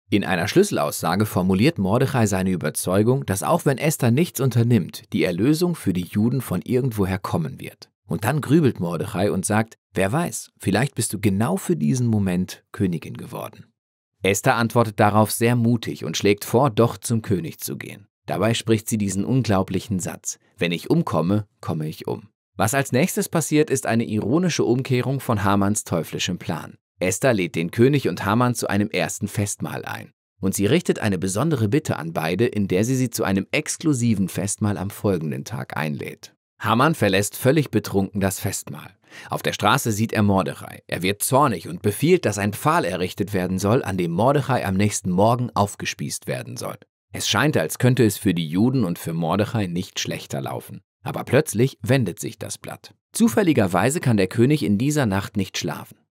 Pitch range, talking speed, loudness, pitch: 95-125 Hz, 180 wpm, -22 LUFS, 110 Hz